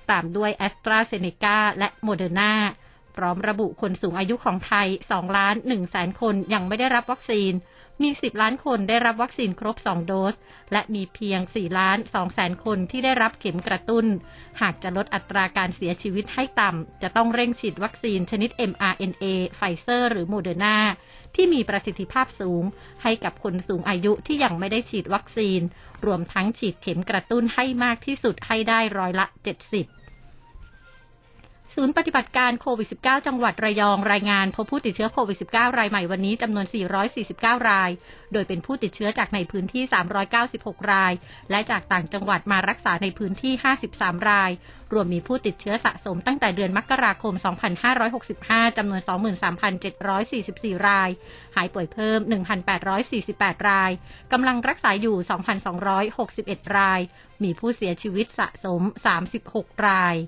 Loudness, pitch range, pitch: -23 LUFS, 190-230 Hz, 205 Hz